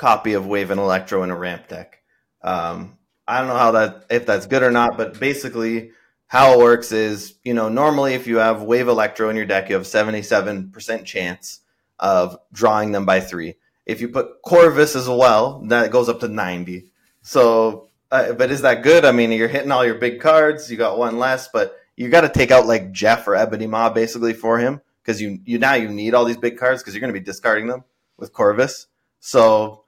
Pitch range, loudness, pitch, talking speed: 105-125 Hz, -17 LUFS, 115 Hz, 220 wpm